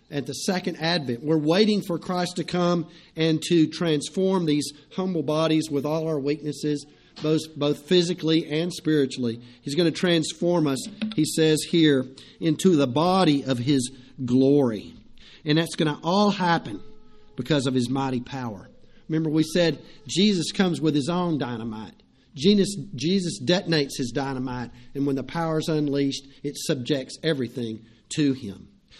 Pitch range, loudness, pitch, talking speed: 135-170 Hz, -24 LUFS, 155 Hz, 155 wpm